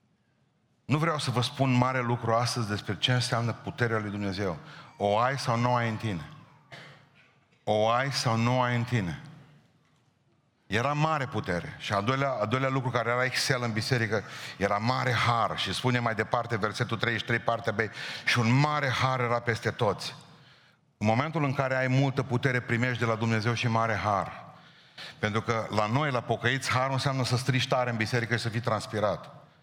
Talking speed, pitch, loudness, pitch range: 185 wpm, 120 Hz, -28 LUFS, 115-130 Hz